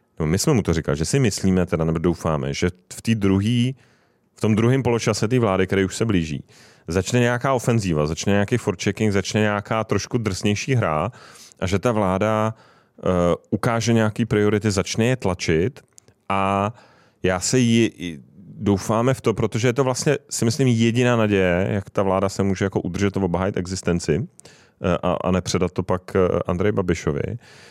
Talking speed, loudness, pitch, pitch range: 170 wpm, -21 LUFS, 100 Hz, 90-115 Hz